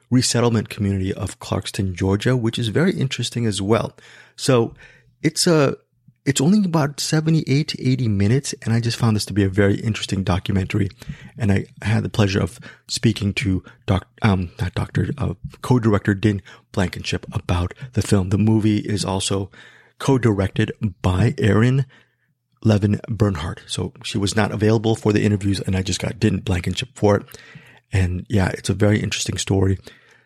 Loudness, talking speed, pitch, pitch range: -21 LUFS, 170 wpm, 110 Hz, 100-125 Hz